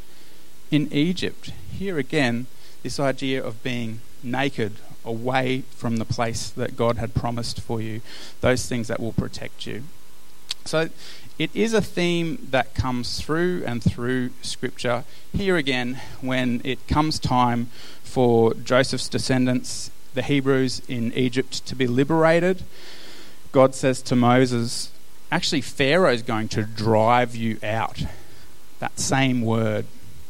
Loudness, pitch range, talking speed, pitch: -23 LUFS, 115-135 Hz, 130 wpm, 125 Hz